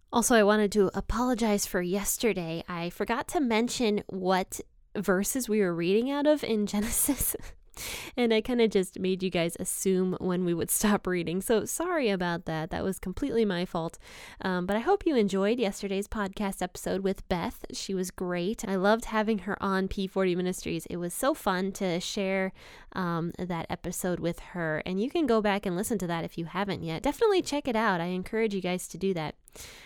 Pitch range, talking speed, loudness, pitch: 180-220 Hz, 200 wpm, -29 LUFS, 195 Hz